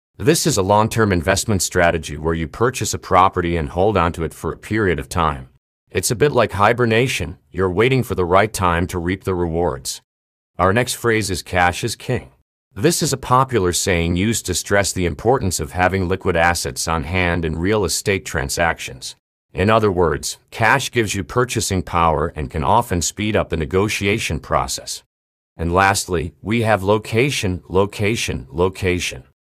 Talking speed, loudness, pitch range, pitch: 175 wpm, -18 LUFS, 85-110 Hz, 90 Hz